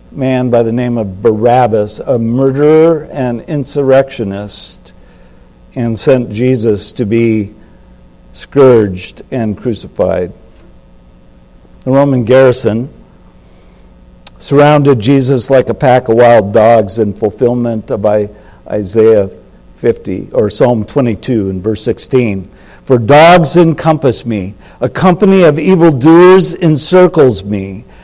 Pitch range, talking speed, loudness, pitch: 105-135 Hz, 105 wpm, -10 LUFS, 120 Hz